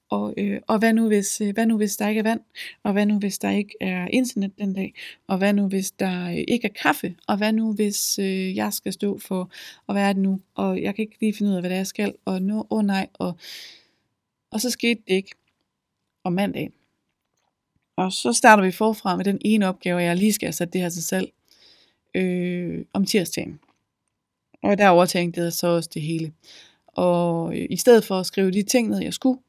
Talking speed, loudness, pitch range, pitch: 230 wpm, -22 LUFS, 185-215 Hz, 195 Hz